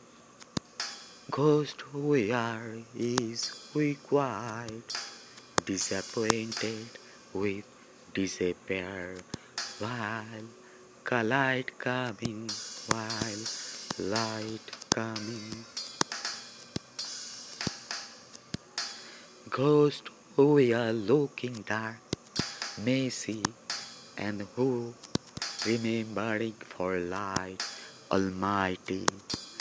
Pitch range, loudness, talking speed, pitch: 105-125 Hz, -32 LUFS, 60 wpm, 115 Hz